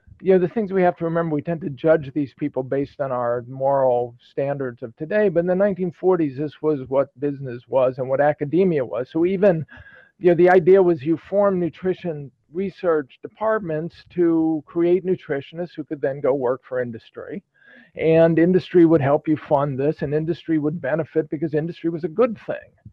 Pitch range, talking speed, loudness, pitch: 140-175 Hz, 190 wpm, -21 LUFS, 160 Hz